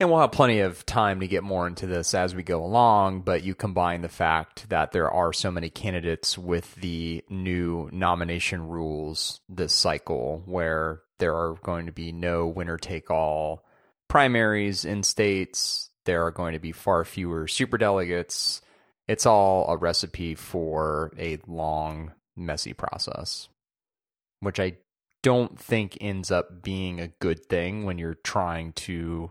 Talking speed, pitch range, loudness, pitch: 160 wpm, 85-95 Hz, -26 LUFS, 90 Hz